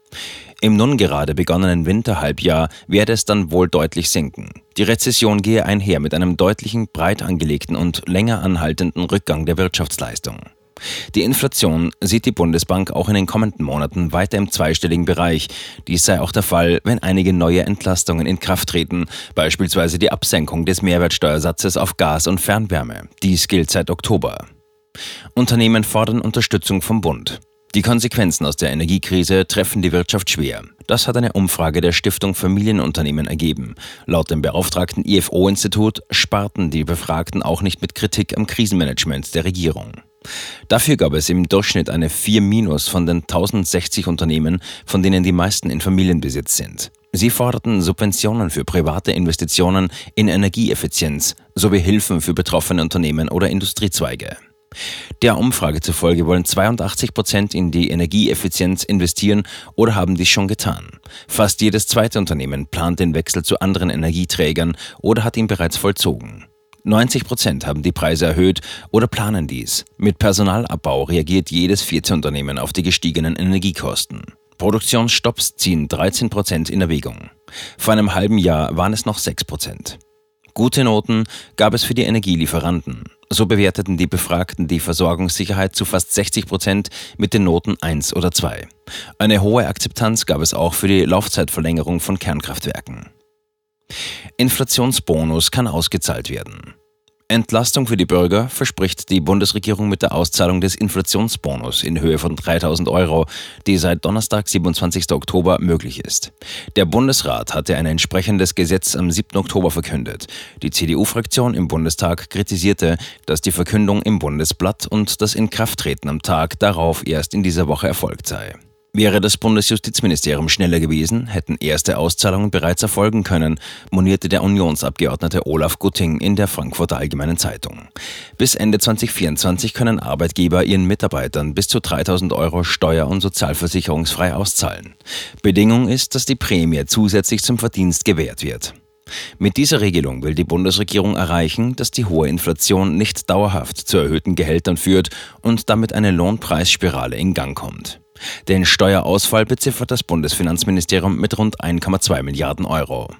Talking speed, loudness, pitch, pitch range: 145 wpm, -17 LUFS, 95 Hz, 85-105 Hz